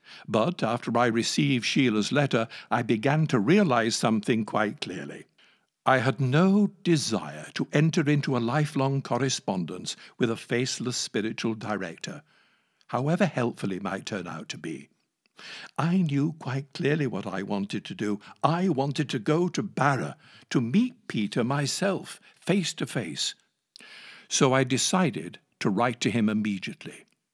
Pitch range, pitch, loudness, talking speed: 115-155 Hz, 130 Hz, -27 LUFS, 145 wpm